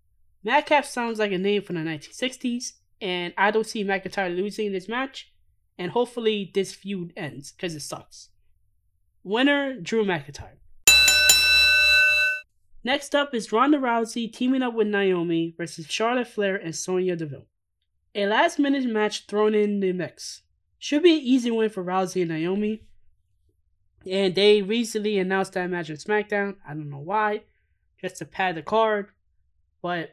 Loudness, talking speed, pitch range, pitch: -22 LUFS, 150 wpm, 165-230 Hz, 200 Hz